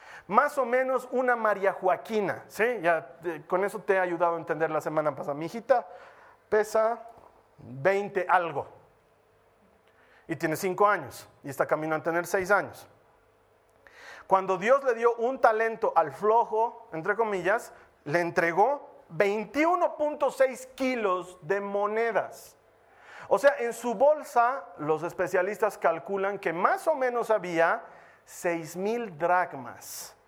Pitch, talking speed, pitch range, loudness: 200 Hz, 130 wpm, 170-235 Hz, -27 LUFS